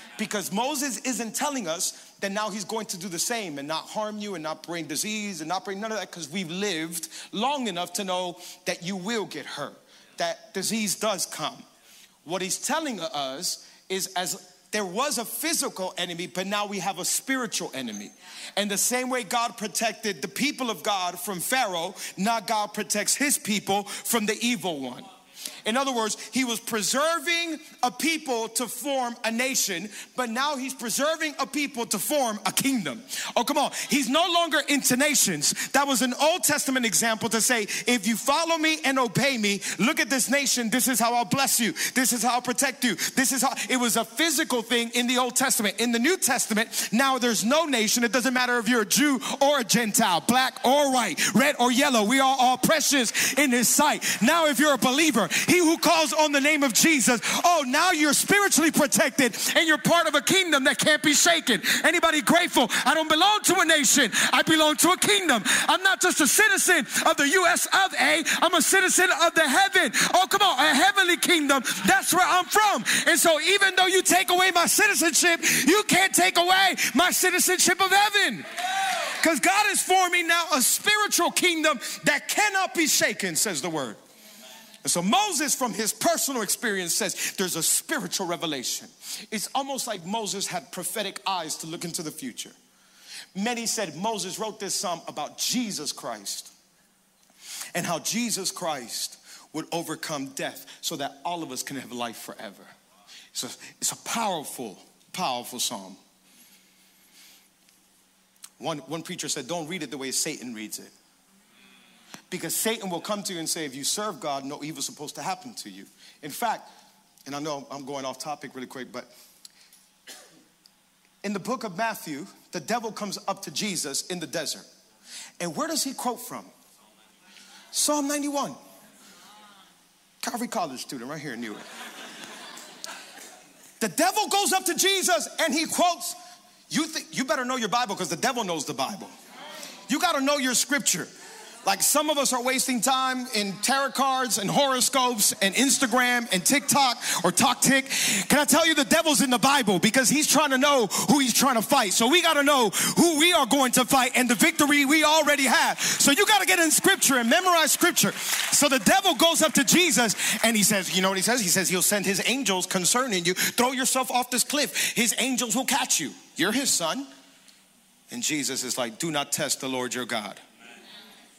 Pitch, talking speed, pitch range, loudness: 250 Hz, 195 wpm, 205-300 Hz, -23 LUFS